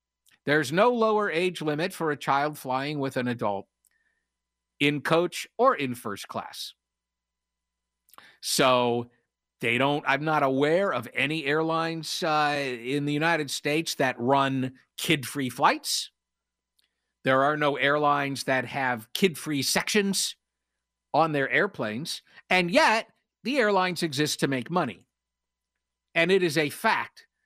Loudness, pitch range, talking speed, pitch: -26 LUFS, 120-165 Hz, 135 wpm, 140 Hz